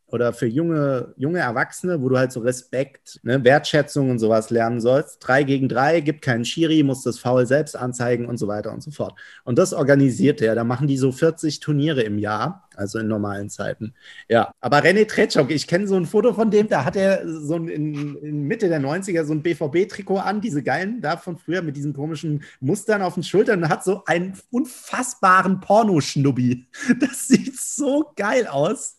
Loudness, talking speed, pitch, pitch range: -21 LUFS, 200 wpm, 150 Hz, 130-185 Hz